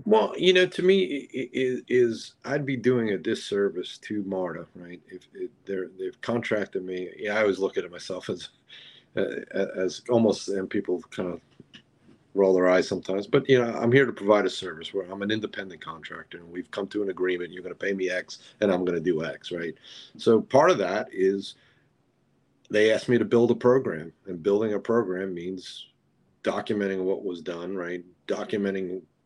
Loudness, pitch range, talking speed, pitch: -26 LUFS, 90-120 Hz, 200 wpm, 100 Hz